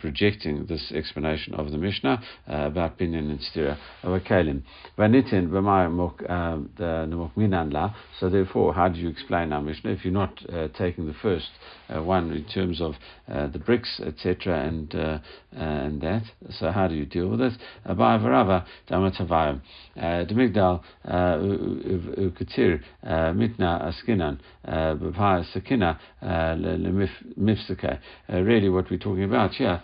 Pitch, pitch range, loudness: 85 Hz, 80-95 Hz, -26 LUFS